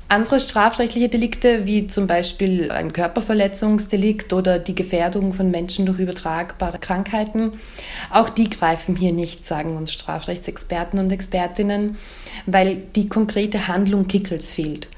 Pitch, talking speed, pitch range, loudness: 190 Hz, 130 wpm, 175-210 Hz, -20 LUFS